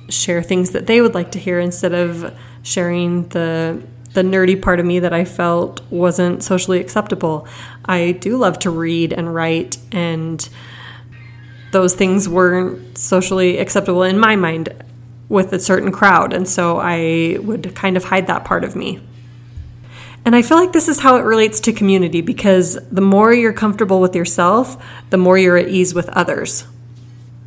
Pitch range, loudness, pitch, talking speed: 165-190 Hz, -14 LUFS, 180 Hz, 175 wpm